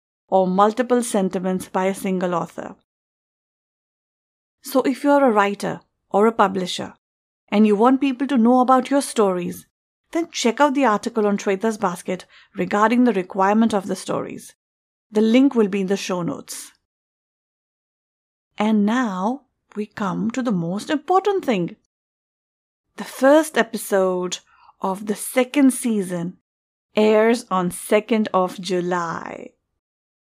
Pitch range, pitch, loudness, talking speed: 190-250 Hz, 210 Hz, -20 LUFS, 135 wpm